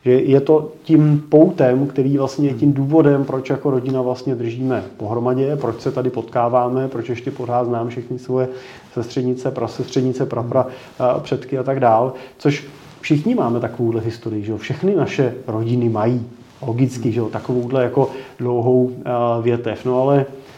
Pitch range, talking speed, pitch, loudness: 120-135 Hz, 165 wpm, 130 Hz, -19 LUFS